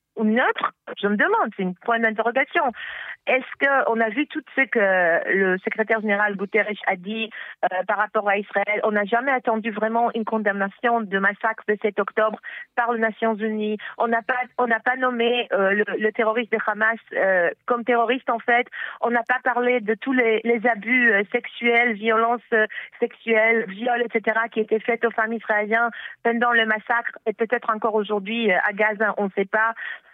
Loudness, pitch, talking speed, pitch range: -22 LUFS, 225 Hz, 195 wpm, 210-240 Hz